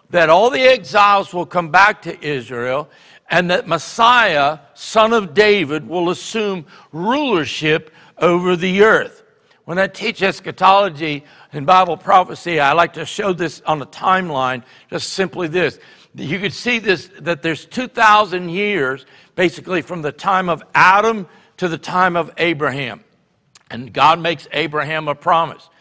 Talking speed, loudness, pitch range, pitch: 150 wpm, -16 LUFS, 155-195 Hz, 175 Hz